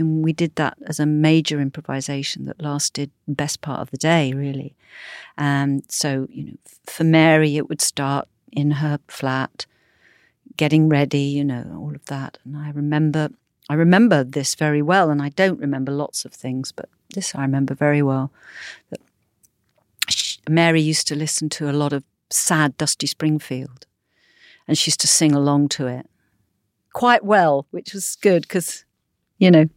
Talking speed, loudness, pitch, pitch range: 175 wpm, -20 LUFS, 145 Hz, 140-155 Hz